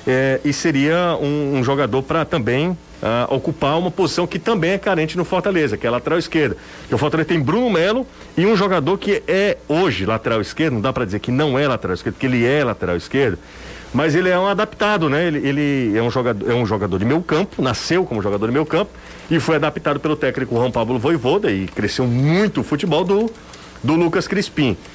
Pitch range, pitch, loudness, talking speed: 125-175 Hz, 150 Hz, -18 LUFS, 220 wpm